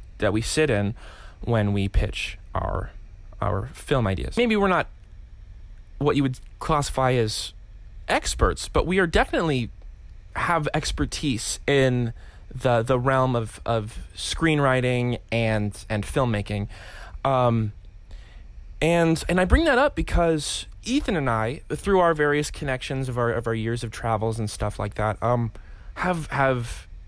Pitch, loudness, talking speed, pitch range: 115 Hz, -24 LUFS, 145 wpm, 100-140 Hz